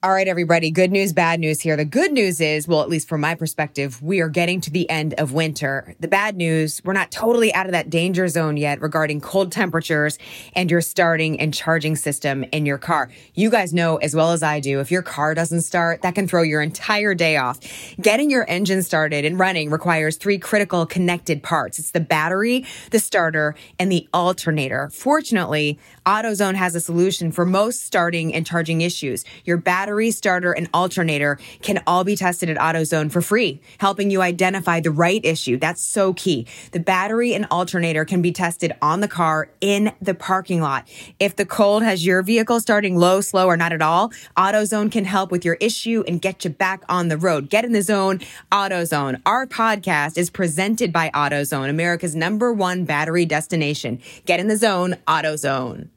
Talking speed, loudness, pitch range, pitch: 195 wpm, -19 LUFS, 155-190 Hz, 175 Hz